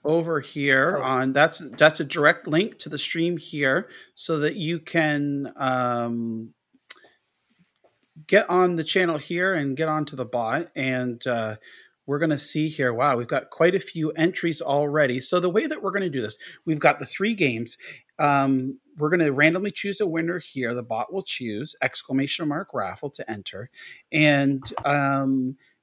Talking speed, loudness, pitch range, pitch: 175 wpm, -24 LUFS, 135-165 Hz, 150 Hz